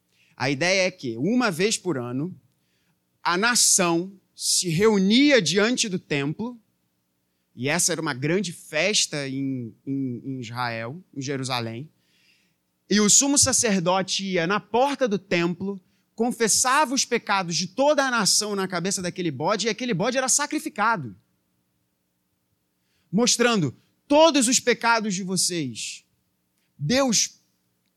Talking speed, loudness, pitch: 125 wpm, -22 LUFS, 180 Hz